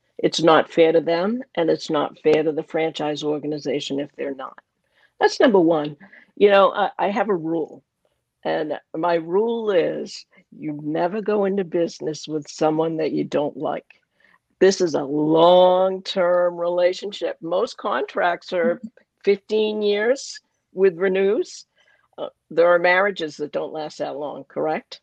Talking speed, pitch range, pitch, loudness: 155 wpm, 160-205 Hz, 180 Hz, -21 LUFS